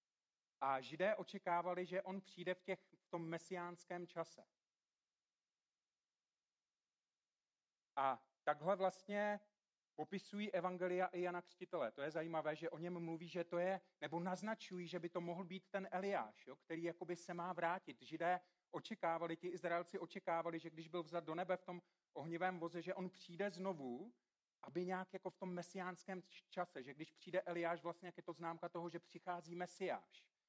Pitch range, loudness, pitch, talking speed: 170-185 Hz, -46 LUFS, 175 Hz, 165 wpm